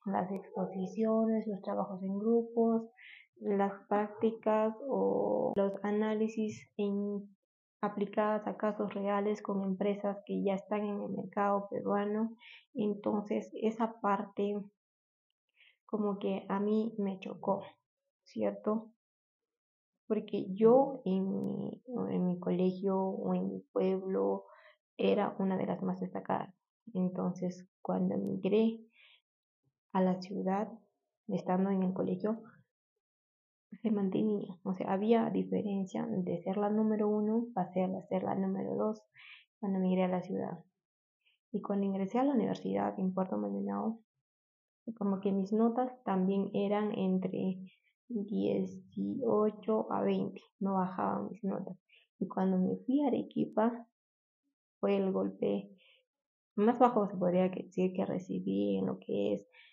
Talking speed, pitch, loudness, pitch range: 125 wpm, 200 Hz, -34 LUFS, 185-220 Hz